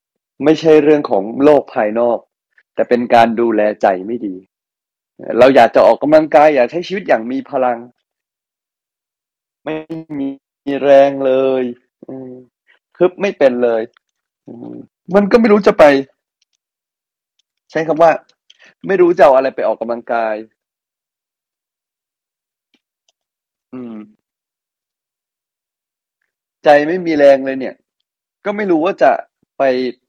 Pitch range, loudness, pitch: 120-165 Hz, -13 LUFS, 140 Hz